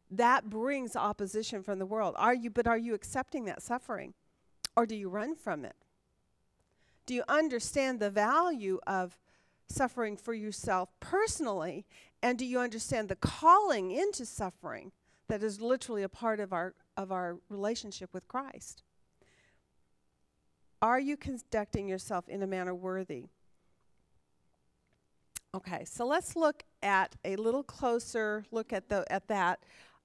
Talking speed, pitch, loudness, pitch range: 140 wpm, 215 Hz, -33 LUFS, 195-245 Hz